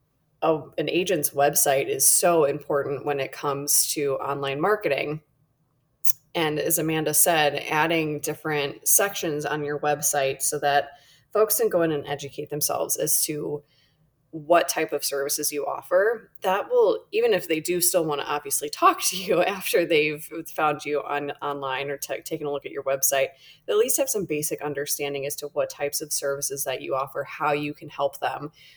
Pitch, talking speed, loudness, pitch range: 145 Hz, 180 wpm, -24 LUFS, 140-160 Hz